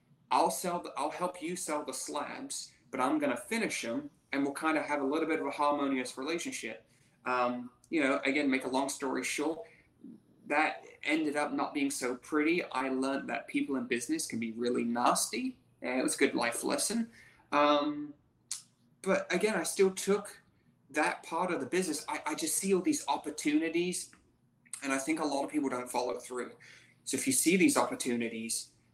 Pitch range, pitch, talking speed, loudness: 130-175 Hz, 145 Hz, 195 wpm, -32 LUFS